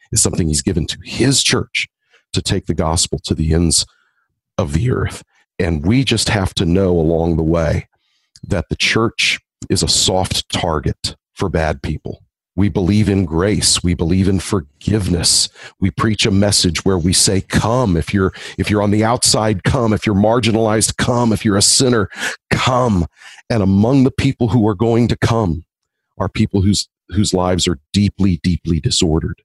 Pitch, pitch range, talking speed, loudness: 100 Hz, 85-110 Hz, 175 wpm, -16 LUFS